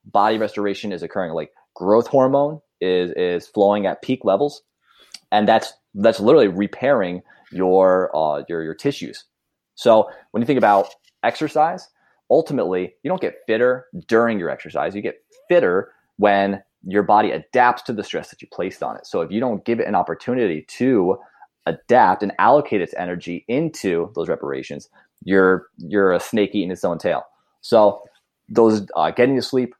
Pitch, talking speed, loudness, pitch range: 105 Hz, 165 wpm, -19 LUFS, 90-130 Hz